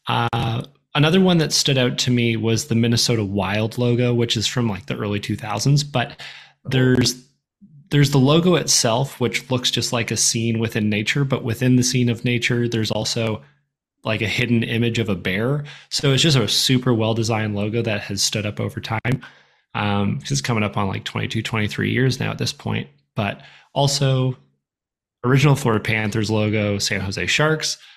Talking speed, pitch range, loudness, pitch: 180 wpm, 110-130 Hz, -20 LUFS, 120 Hz